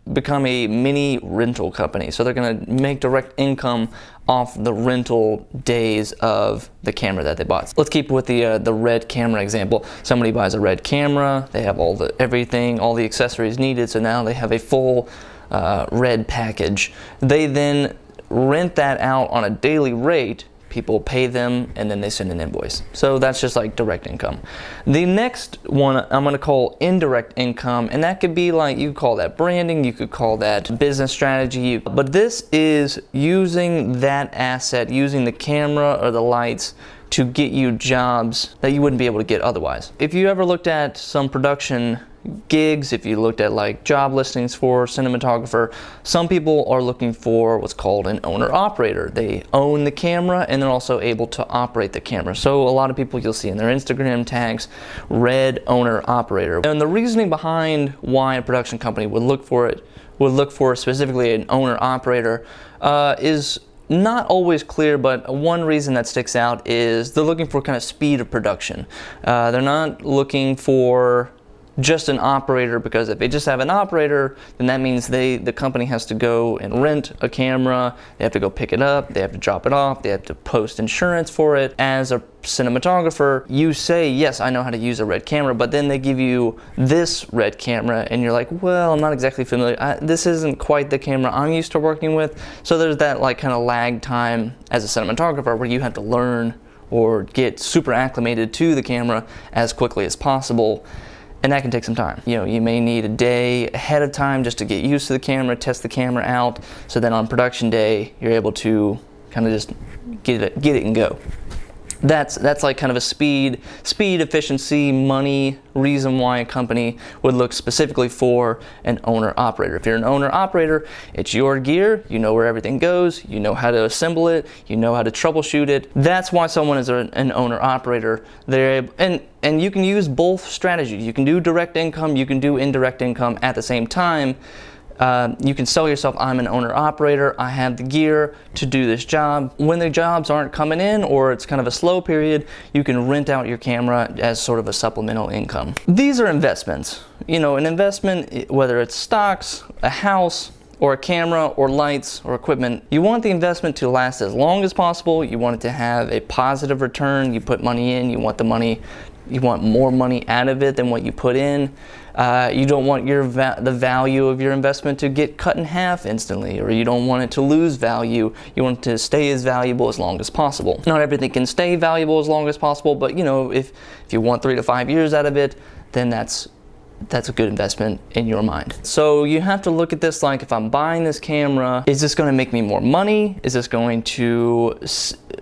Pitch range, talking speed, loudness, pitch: 120-145 Hz, 210 wpm, -19 LUFS, 130 Hz